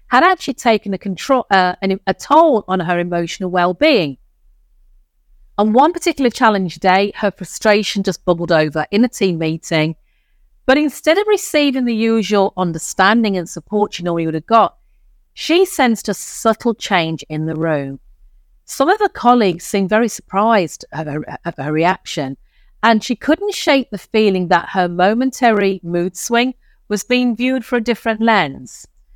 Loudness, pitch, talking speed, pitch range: -16 LUFS, 200 Hz, 160 wpm, 170-240 Hz